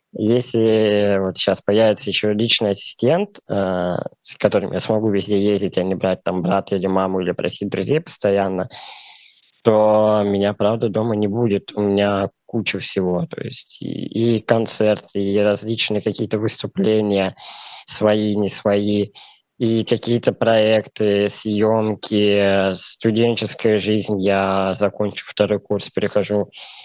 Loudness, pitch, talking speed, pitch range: -19 LUFS, 105 Hz, 130 wpm, 100-110 Hz